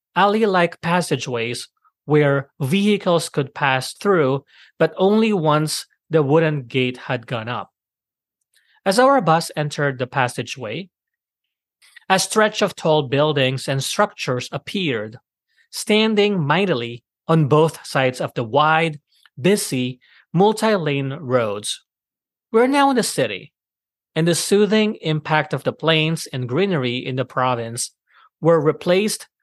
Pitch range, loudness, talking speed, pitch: 135-195 Hz, -19 LUFS, 125 wpm, 155 Hz